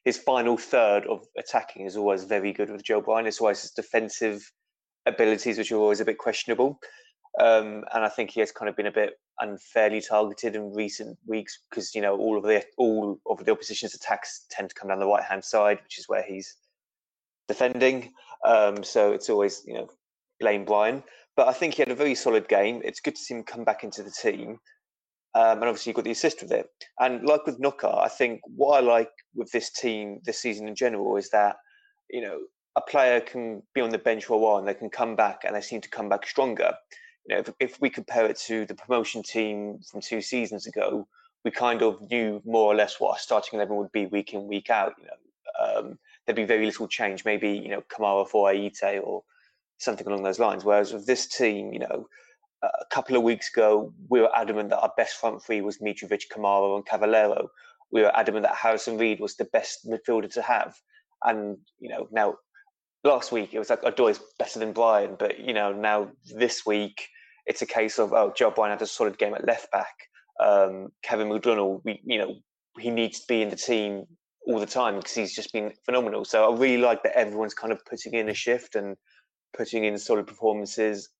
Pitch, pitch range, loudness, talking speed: 110 Hz, 105-140 Hz, -26 LUFS, 220 wpm